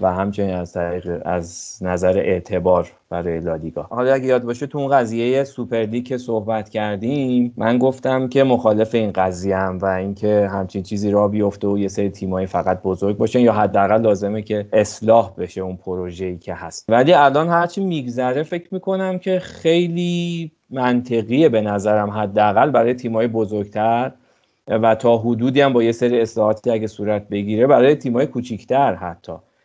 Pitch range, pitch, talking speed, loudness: 95-125 Hz, 110 Hz, 160 wpm, -19 LUFS